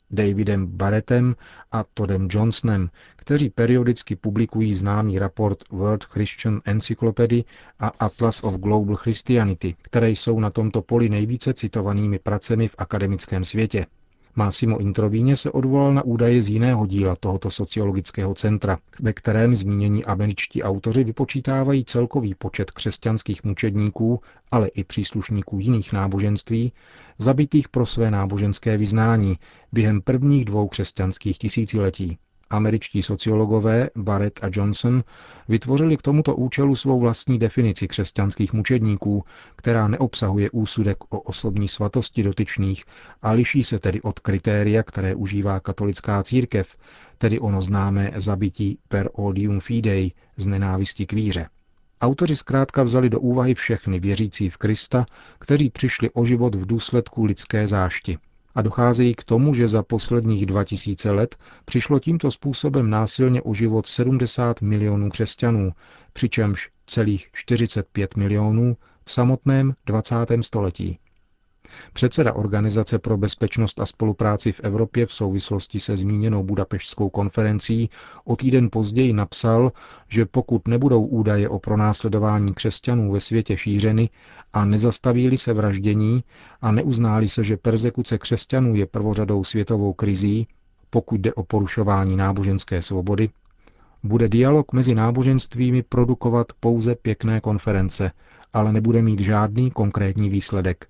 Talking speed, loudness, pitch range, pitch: 125 wpm, -21 LUFS, 100-120 Hz, 110 Hz